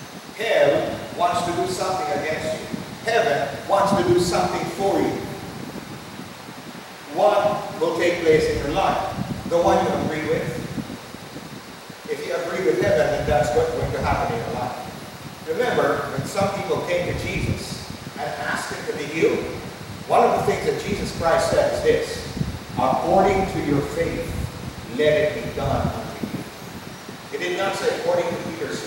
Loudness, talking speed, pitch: -22 LUFS, 165 wpm, 195 Hz